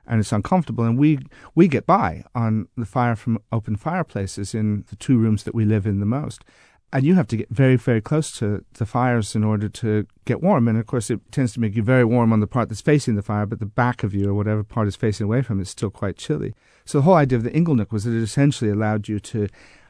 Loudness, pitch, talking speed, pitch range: -21 LUFS, 115 Hz, 260 wpm, 105-125 Hz